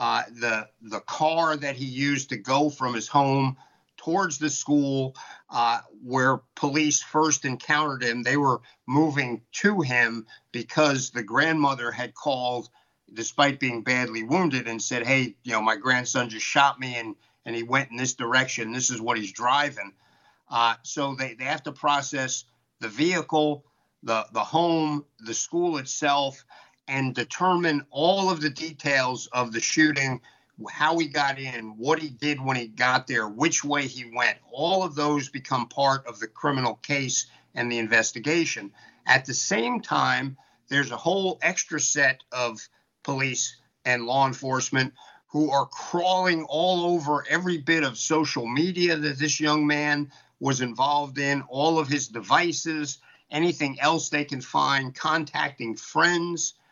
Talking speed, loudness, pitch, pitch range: 160 wpm, -25 LUFS, 140 Hz, 125-155 Hz